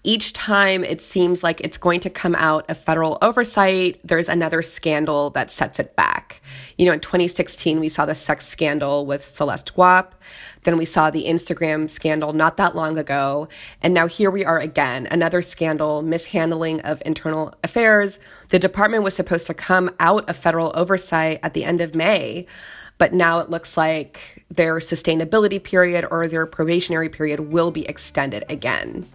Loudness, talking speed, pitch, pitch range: -19 LUFS, 175 wpm, 165 Hz, 155-180 Hz